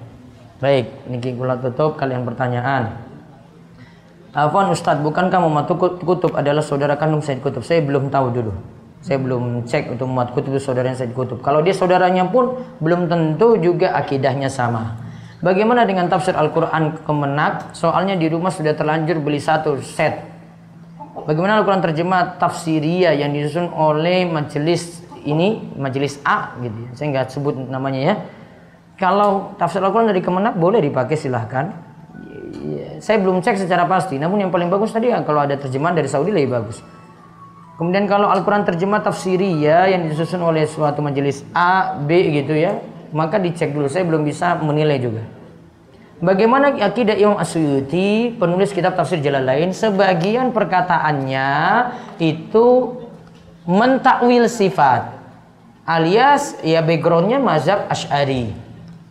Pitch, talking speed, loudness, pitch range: 165 Hz, 140 wpm, -18 LUFS, 140-185 Hz